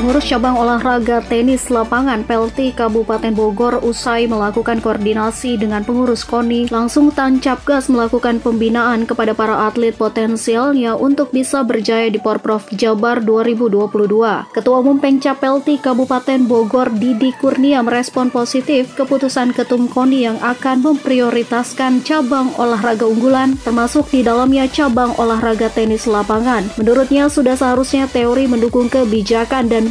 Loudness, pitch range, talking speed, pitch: -14 LUFS, 230-260 Hz, 125 wpm, 240 Hz